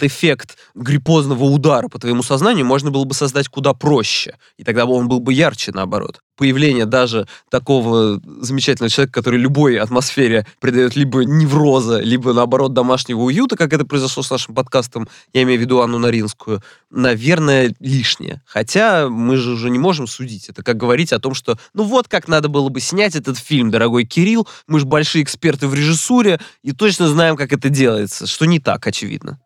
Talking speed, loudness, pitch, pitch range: 180 wpm, -15 LUFS, 135 Hz, 125-150 Hz